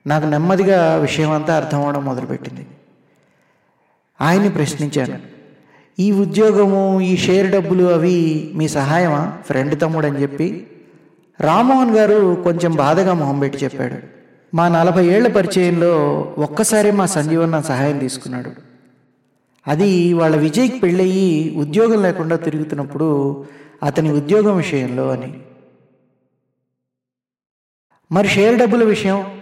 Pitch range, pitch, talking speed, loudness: 140-190 Hz, 160 Hz, 105 wpm, -16 LUFS